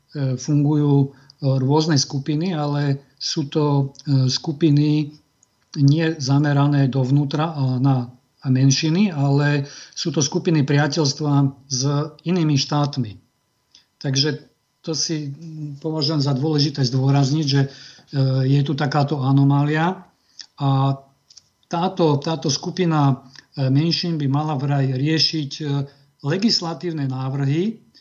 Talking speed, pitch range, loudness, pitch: 95 wpm, 135-155 Hz, -20 LUFS, 145 Hz